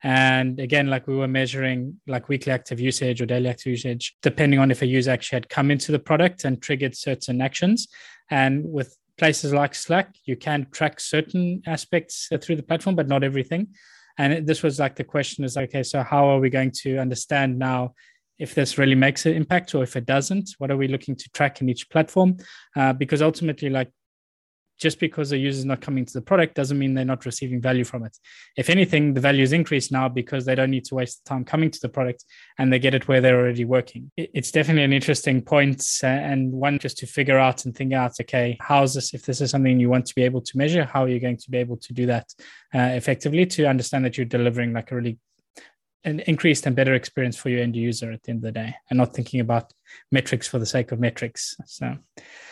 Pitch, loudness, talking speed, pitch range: 135 Hz, -22 LUFS, 230 wpm, 125-145 Hz